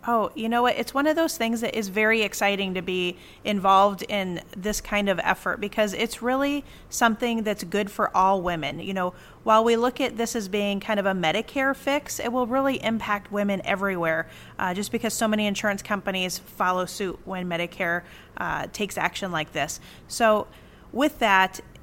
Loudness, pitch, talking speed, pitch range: -25 LUFS, 205 Hz, 190 wpm, 190-230 Hz